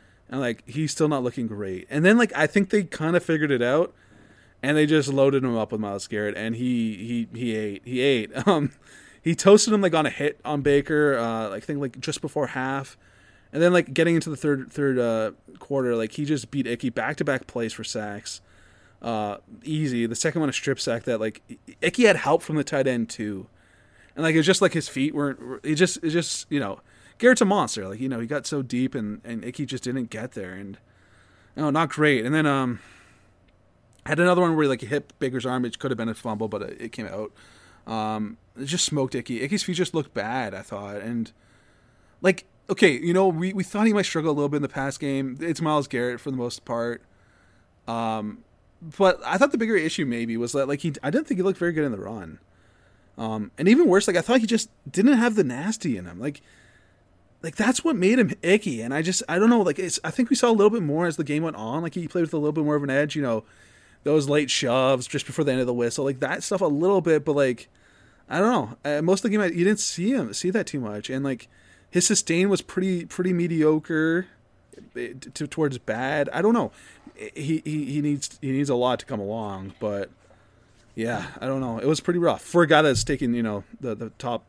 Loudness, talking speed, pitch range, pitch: -24 LUFS, 245 wpm, 115-165 Hz, 140 Hz